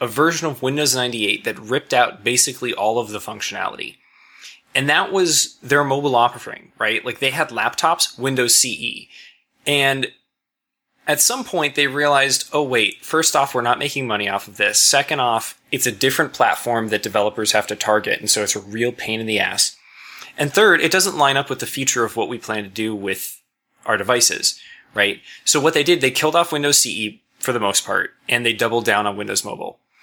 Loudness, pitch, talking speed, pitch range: -18 LUFS, 130 Hz, 205 wpm, 110-150 Hz